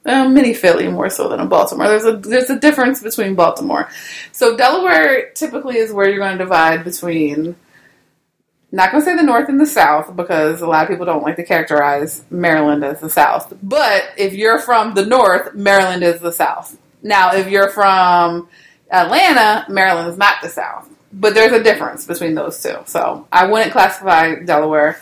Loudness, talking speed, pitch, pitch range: -13 LUFS, 185 wpm, 195 Hz, 170-225 Hz